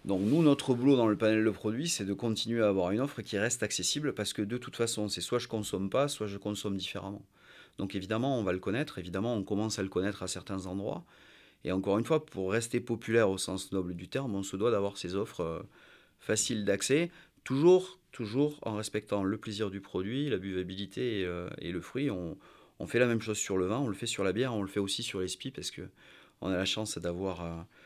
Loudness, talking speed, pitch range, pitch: -32 LUFS, 245 wpm, 95-120 Hz, 105 Hz